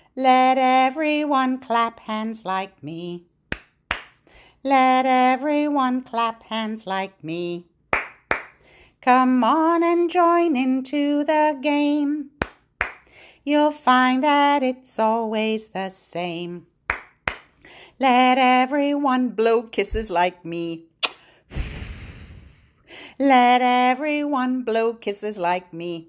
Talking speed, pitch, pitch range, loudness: 85 wpm, 255 Hz, 210-285 Hz, -21 LUFS